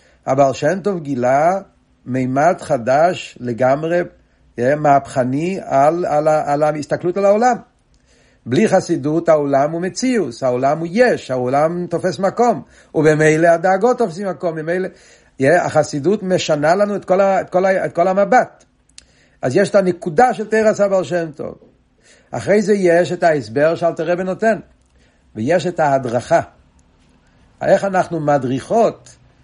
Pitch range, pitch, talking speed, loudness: 145-190 Hz, 170 Hz, 140 wpm, -16 LUFS